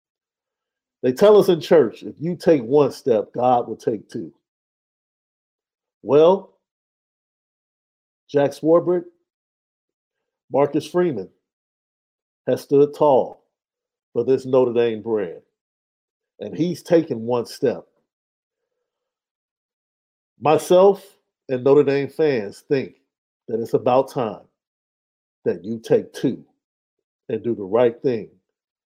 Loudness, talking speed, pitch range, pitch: -20 LUFS, 105 wpm, 125-200 Hz, 150 Hz